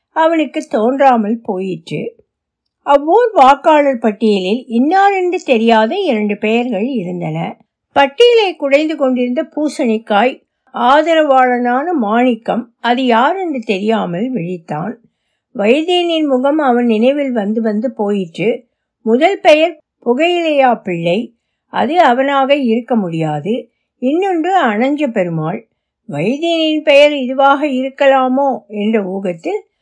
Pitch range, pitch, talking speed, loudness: 220-300 Hz, 255 Hz, 95 wpm, -13 LUFS